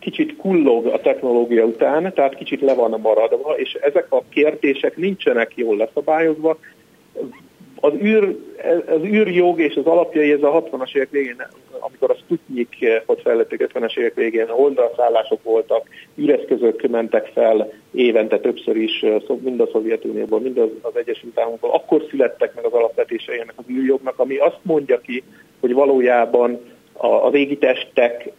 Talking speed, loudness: 150 wpm, -18 LUFS